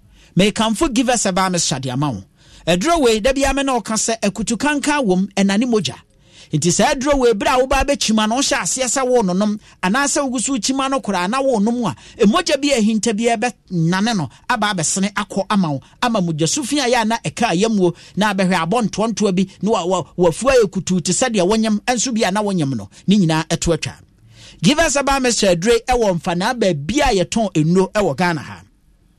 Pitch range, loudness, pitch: 175-245 Hz, -17 LUFS, 210 Hz